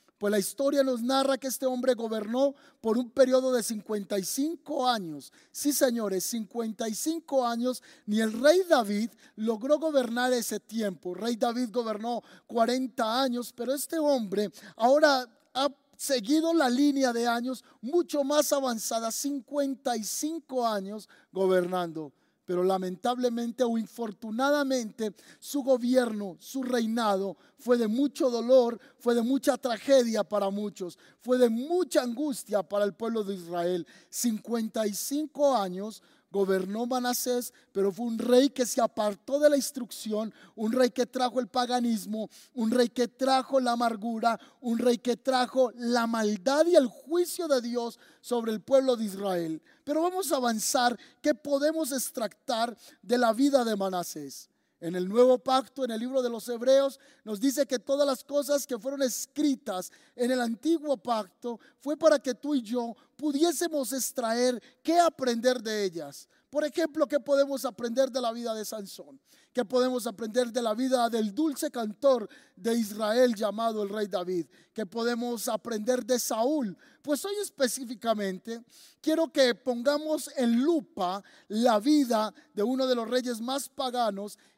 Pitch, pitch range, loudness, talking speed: 245 Hz, 220-275 Hz, -28 LUFS, 150 wpm